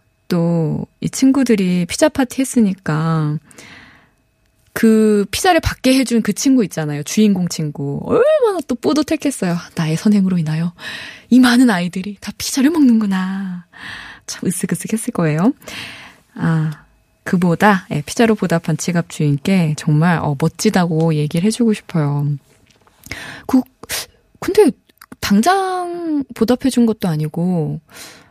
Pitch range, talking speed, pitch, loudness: 165-245 Hz, 260 characters per minute, 195 Hz, -16 LUFS